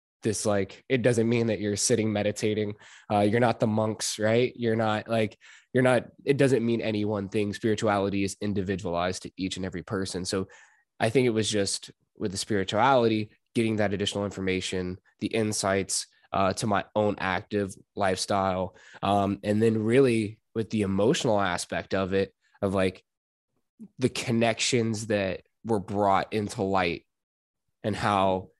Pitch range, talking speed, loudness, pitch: 95-115 Hz, 160 wpm, -27 LUFS, 105 Hz